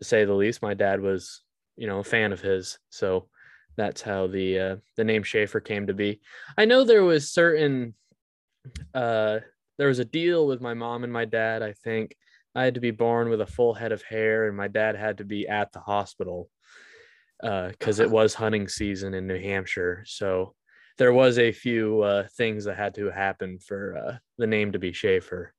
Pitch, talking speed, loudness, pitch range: 110 Hz, 210 wpm, -25 LUFS, 100-120 Hz